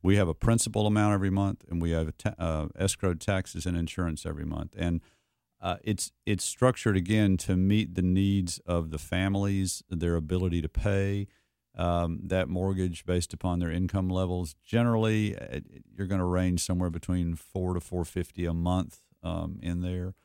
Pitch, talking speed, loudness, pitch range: 90 Hz, 175 wpm, -29 LUFS, 85-100 Hz